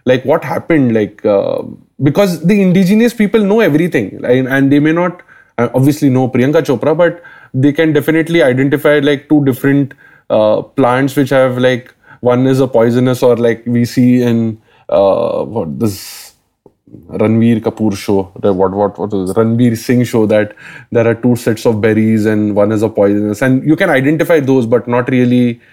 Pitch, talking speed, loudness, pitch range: 125 Hz, 180 wpm, -12 LUFS, 115-145 Hz